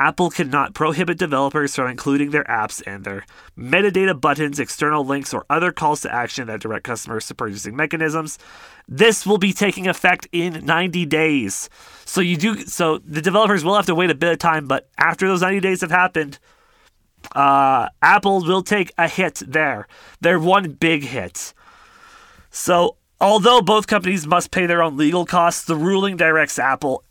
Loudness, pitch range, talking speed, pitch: -18 LUFS, 150-190 Hz, 175 wpm, 170 Hz